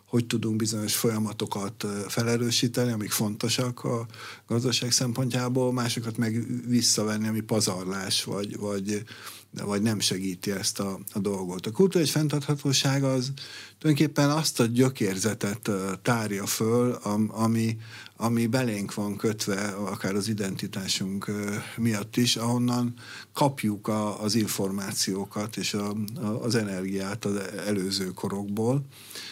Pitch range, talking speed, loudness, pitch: 100-120 Hz, 115 wpm, -27 LUFS, 110 Hz